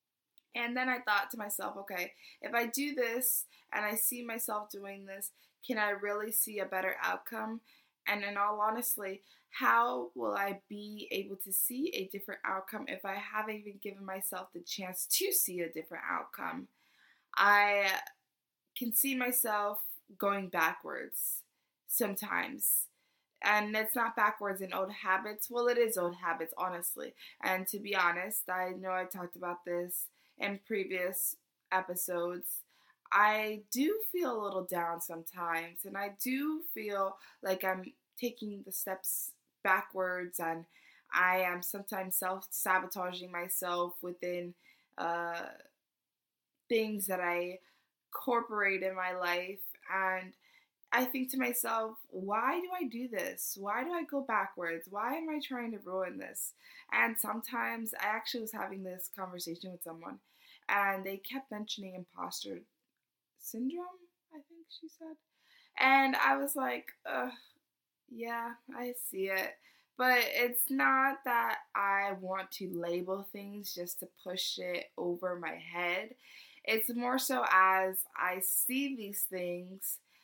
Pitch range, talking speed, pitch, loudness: 185-240 Hz, 145 wpm, 200 Hz, -34 LUFS